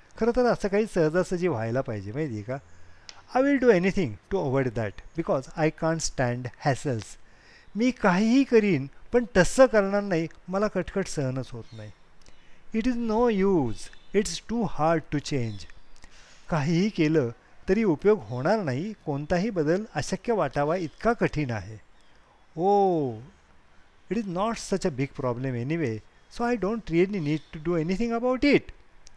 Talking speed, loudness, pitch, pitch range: 155 wpm, -26 LUFS, 165 Hz, 130-210 Hz